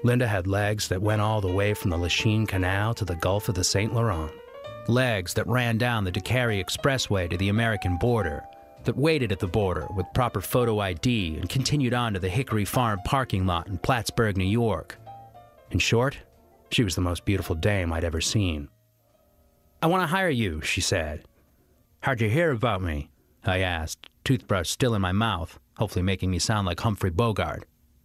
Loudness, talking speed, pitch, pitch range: -26 LUFS, 190 wpm, 105 Hz, 90-120 Hz